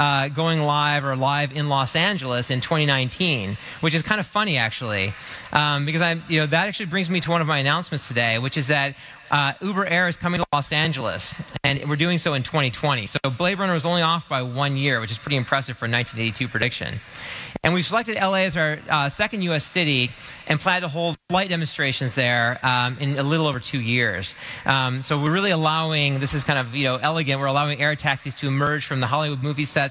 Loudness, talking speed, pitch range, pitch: -22 LUFS, 225 wpm, 135-165 Hz, 145 Hz